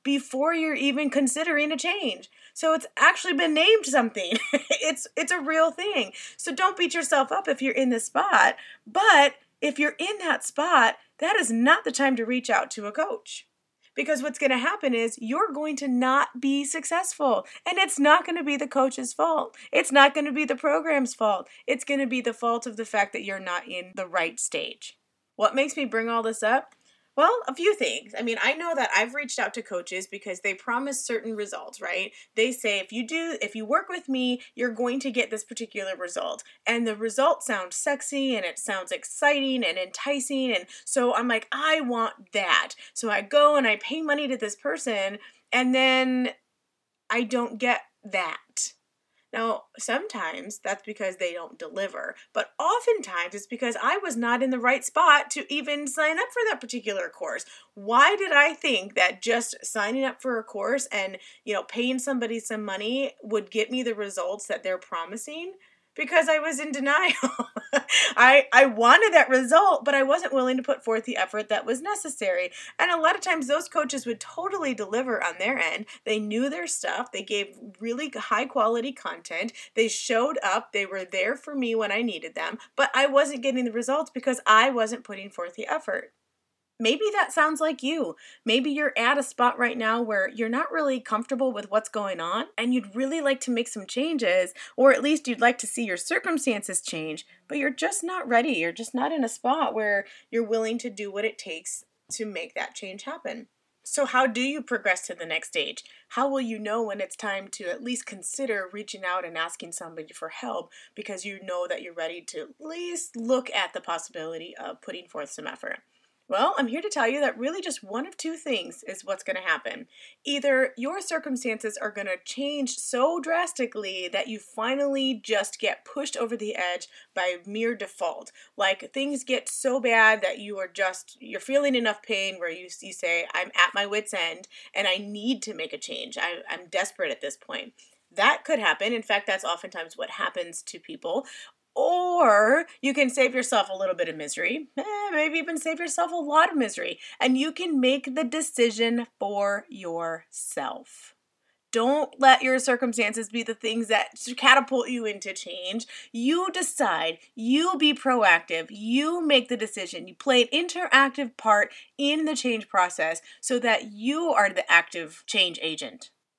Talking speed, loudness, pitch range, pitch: 195 wpm, -25 LUFS, 215-290 Hz, 255 Hz